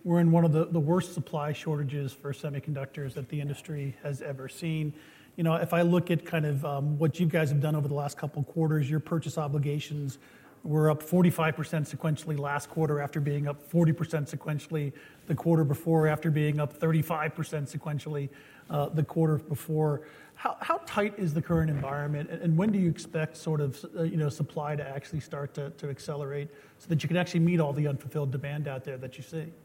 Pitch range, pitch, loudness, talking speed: 145-160 Hz, 150 Hz, -30 LUFS, 205 wpm